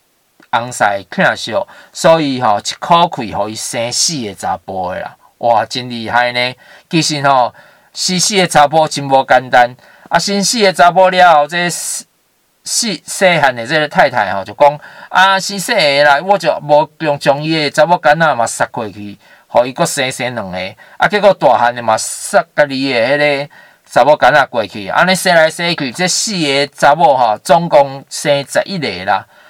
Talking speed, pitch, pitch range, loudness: 260 characters per minute, 145 Hz, 130-175 Hz, -12 LUFS